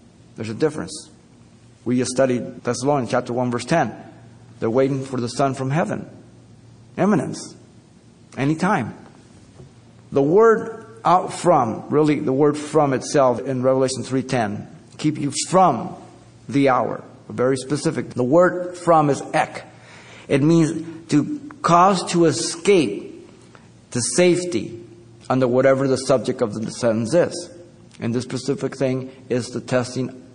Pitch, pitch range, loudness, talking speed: 135 Hz, 125-160 Hz, -20 LUFS, 135 wpm